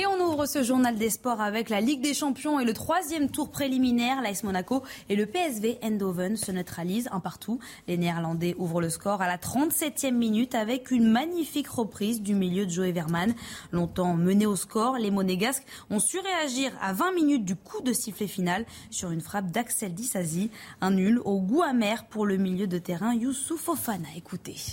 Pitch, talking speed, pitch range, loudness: 220 Hz, 195 wpm, 190-260 Hz, -28 LUFS